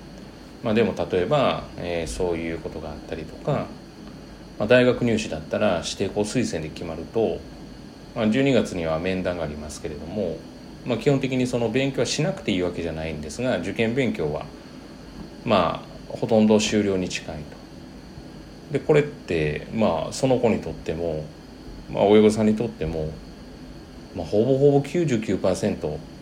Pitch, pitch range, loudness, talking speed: 95 Hz, 80-115 Hz, -24 LUFS, 305 characters per minute